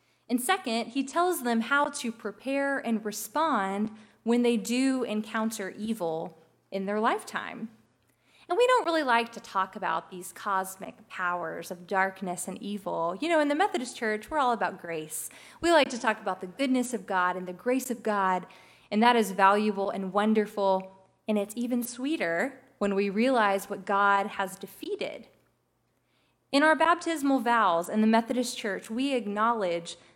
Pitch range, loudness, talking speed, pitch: 195-250 Hz, -28 LUFS, 165 wpm, 215 Hz